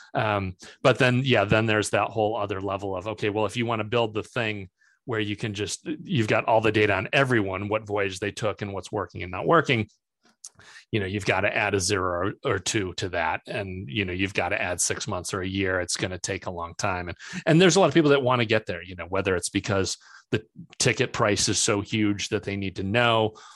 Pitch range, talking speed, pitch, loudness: 95-115 Hz, 255 wpm, 105 Hz, -25 LUFS